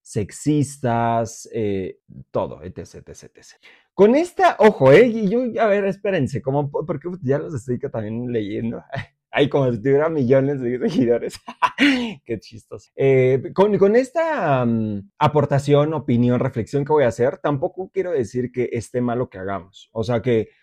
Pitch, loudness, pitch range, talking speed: 135 Hz, -20 LUFS, 120-180 Hz, 165 wpm